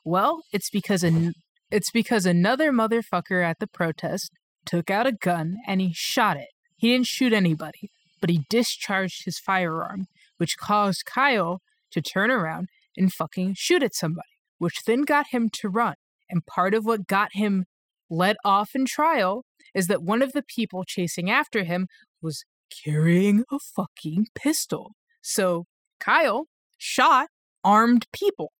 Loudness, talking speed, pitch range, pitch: -24 LUFS, 155 wpm, 175-235 Hz, 195 Hz